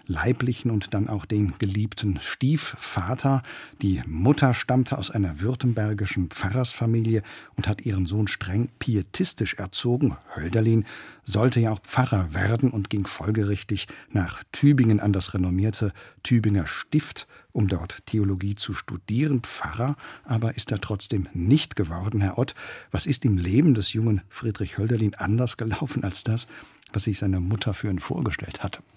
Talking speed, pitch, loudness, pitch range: 145 wpm, 110 Hz, -25 LUFS, 100-125 Hz